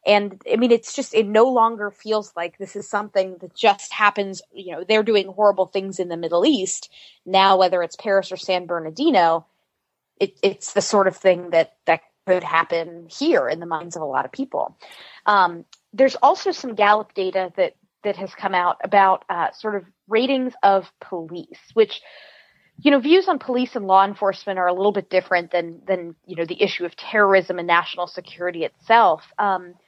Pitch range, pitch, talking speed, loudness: 175-215 Hz, 195 Hz, 195 wpm, -20 LUFS